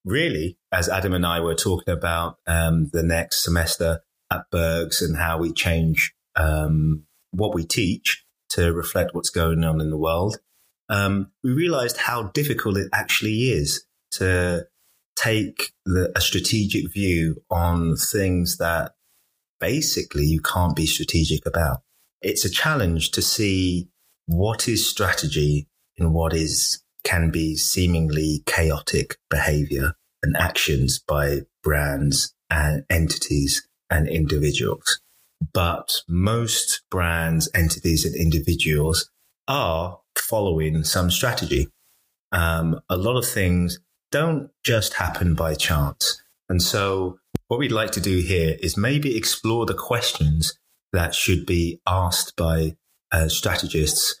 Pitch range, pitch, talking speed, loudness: 80-95 Hz, 85 Hz, 130 wpm, -22 LUFS